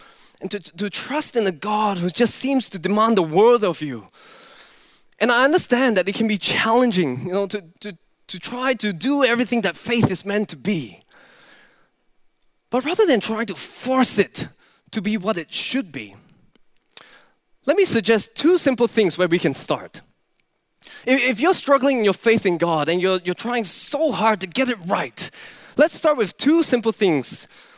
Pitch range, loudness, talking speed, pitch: 190-255 Hz, -20 LUFS, 190 wpm, 220 Hz